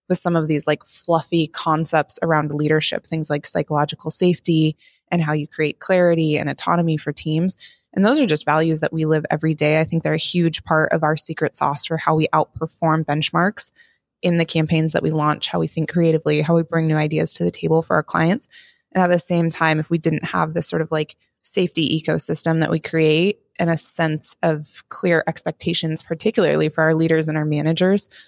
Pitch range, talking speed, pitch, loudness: 155-170 Hz, 210 wpm, 160 Hz, -19 LUFS